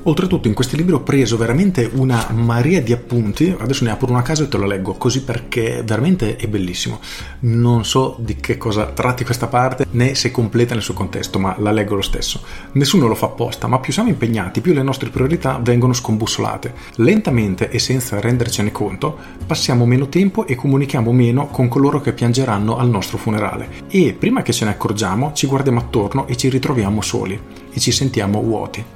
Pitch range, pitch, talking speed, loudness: 110-135 Hz, 120 Hz, 195 wpm, -17 LUFS